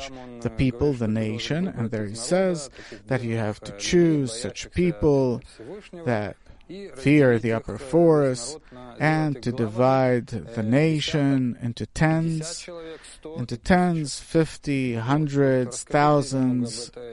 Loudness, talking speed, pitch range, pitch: -23 LUFS, 110 wpm, 120-155 Hz, 130 Hz